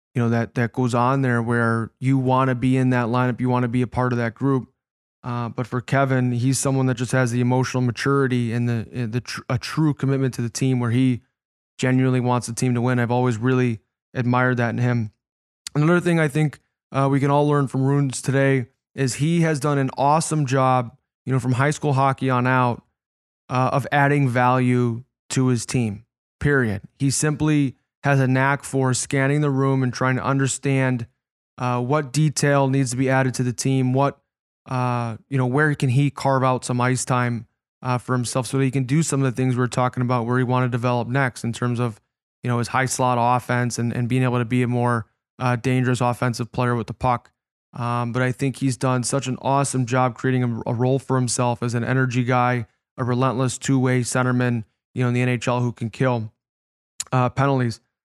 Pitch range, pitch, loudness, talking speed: 120-135 Hz, 125 Hz, -21 LUFS, 215 wpm